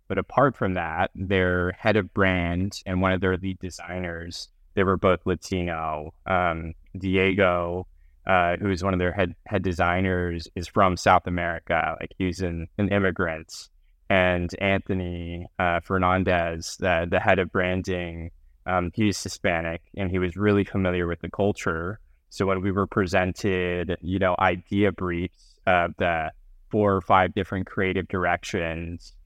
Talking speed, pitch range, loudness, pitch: 155 wpm, 85-95 Hz, -25 LUFS, 90 Hz